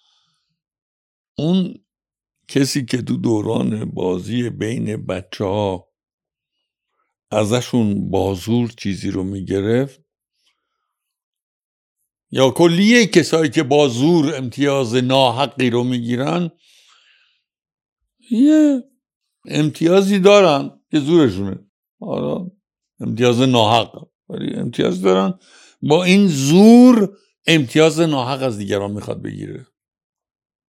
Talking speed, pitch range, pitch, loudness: 85 wpm, 120-180 Hz, 140 Hz, -16 LUFS